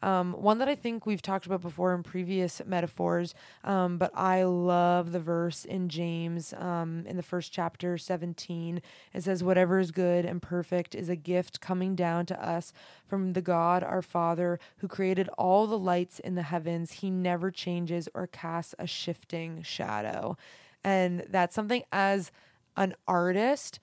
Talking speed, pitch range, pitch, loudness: 170 wpm, 170-185 Hz, 180 Hz, -30 LUFS